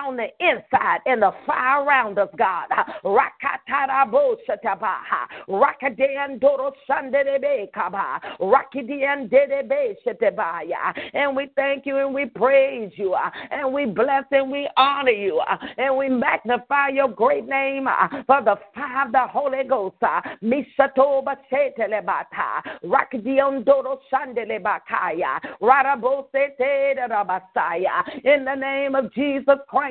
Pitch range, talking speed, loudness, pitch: 255-280 Hz, 120 wpm, -21 LUFS, 275 Hz